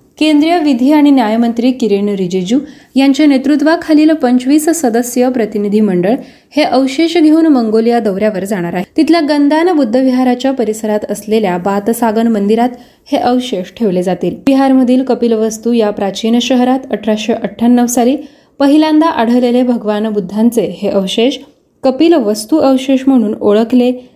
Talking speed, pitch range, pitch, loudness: 125 wpm, 215-275 Hz, 245 Hz, -11 LUFS